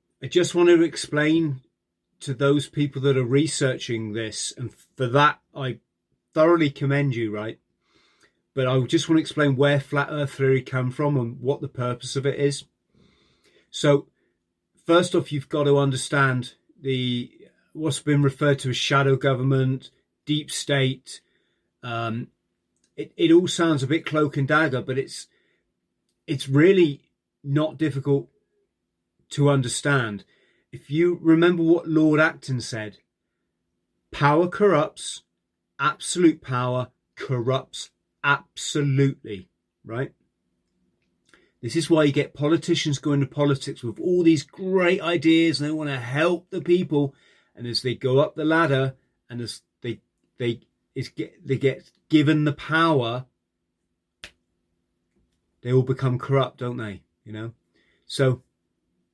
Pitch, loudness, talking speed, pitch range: 135 Hz, -23 LUFS, 140 wpm, 120-155 Hz